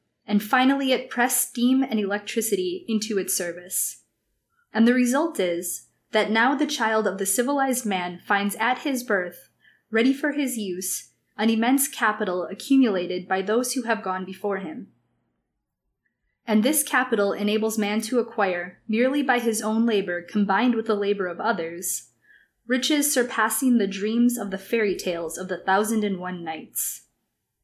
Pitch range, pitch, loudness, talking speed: 190-245 Hz, 215 Hz, -24 LUFS, 160 wpm